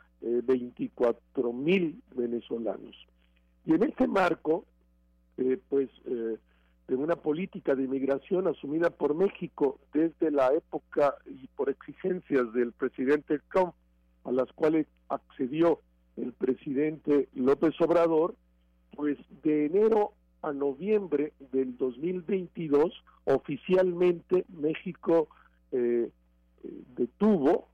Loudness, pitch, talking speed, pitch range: -29 LUFS, 145 Hz, 105 wpm, 120-175 Hz